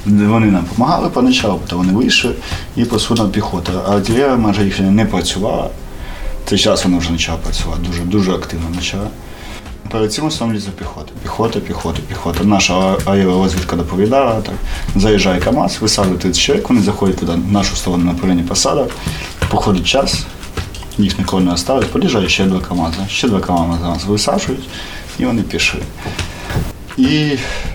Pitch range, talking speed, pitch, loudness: 85-105 Hz, 150 wpm, 95 Hz, -15 LUFS